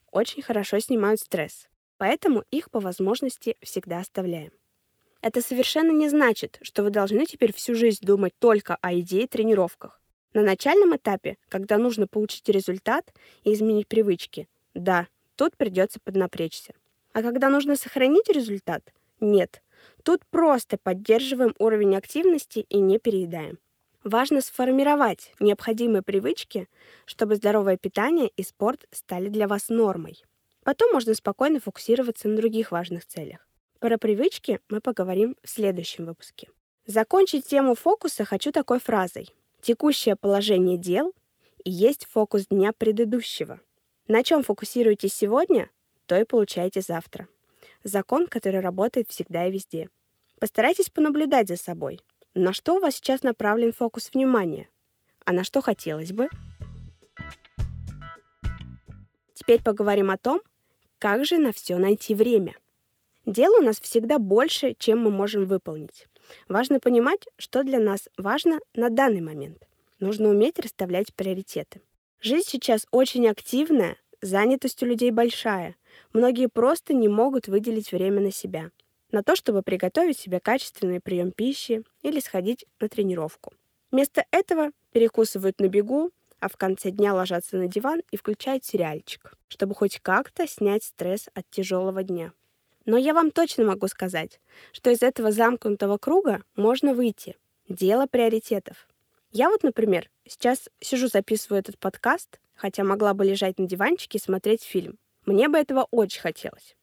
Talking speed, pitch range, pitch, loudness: 140 wpm, 195-255 Hz, 220 Hz, -24 LUFS